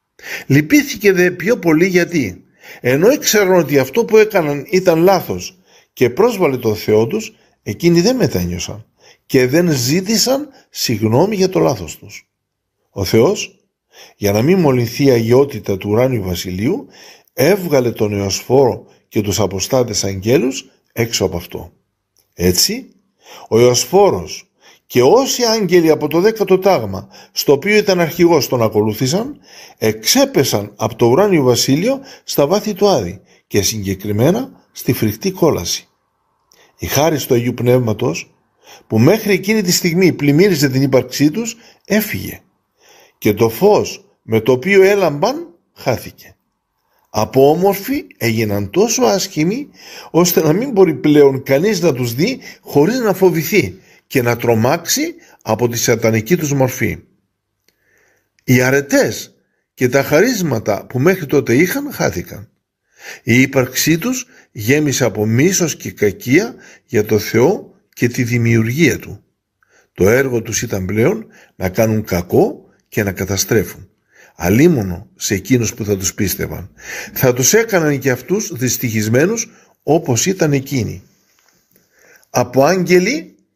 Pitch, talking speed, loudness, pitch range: 135 Hz, 130 wpm, -15 LUFS, 115-185 Hz